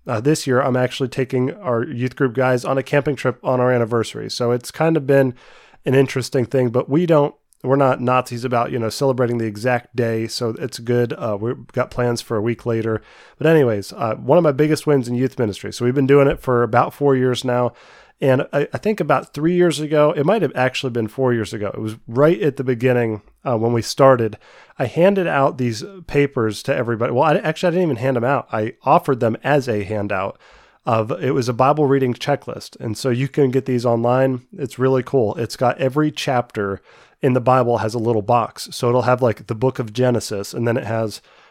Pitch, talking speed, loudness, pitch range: 125 Hz, 225 wpm, -19 LUFS, 120-140 Hz